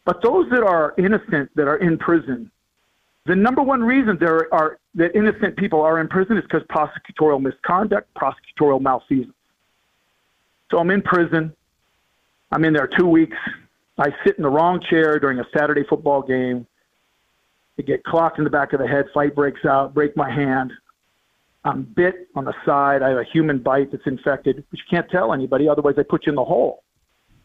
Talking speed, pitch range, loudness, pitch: 190 wpm, 140-175 Hz, -19 LUFS, 155 Hz